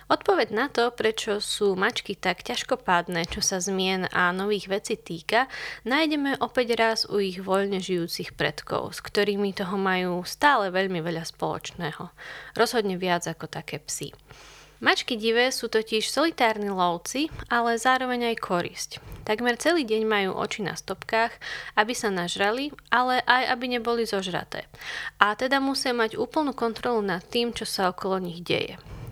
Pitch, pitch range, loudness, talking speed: 215 Hz, 190-245 Hz, -26 LUFS, 150 wpm